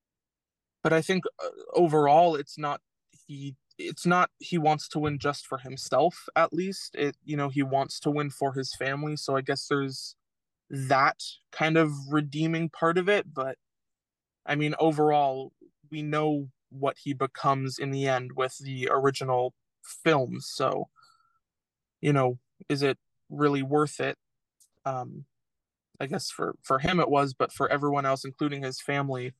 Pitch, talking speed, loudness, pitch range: 145 Hz, 160 wpm, -28 LUFS, 135-155 Hz